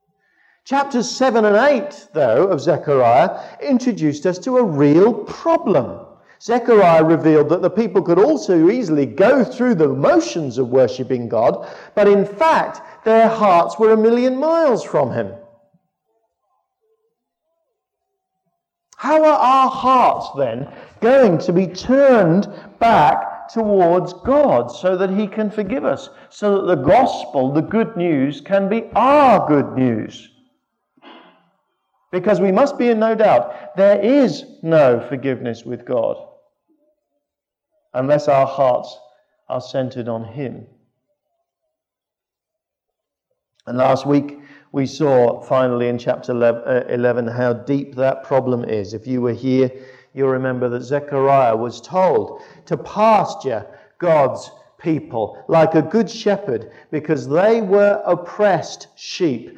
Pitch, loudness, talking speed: 190 Hz, -16 LUFS, 125 wpm